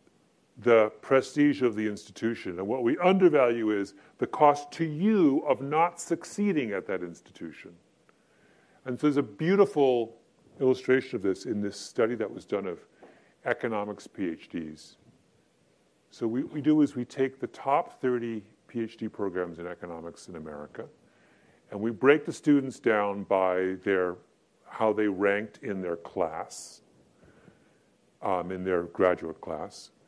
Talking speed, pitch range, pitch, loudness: 145 wpm, 100-145 Hz, 115 Hz, -28 LUFS